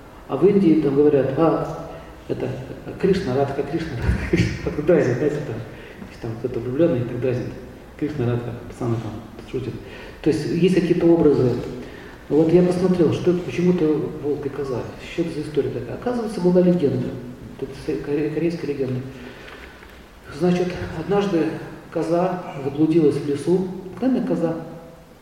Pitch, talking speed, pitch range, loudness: 155 Hz, 120 wpm, 130-175 Hz, -21 LUFS